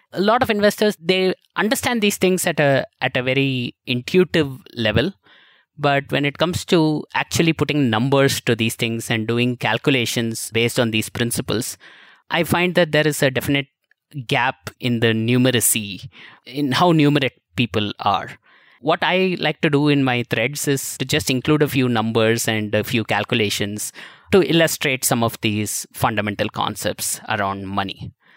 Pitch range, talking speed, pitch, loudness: 115-155 Hz, 165 wpm, 130 Hz, -19 LUFS